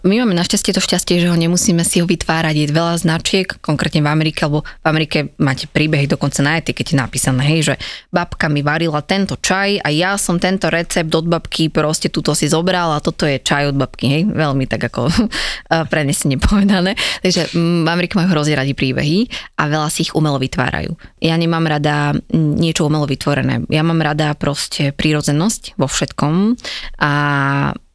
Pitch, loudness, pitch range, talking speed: 160 Hz, -16 LUFS, 145-175 Hz, 180 wpm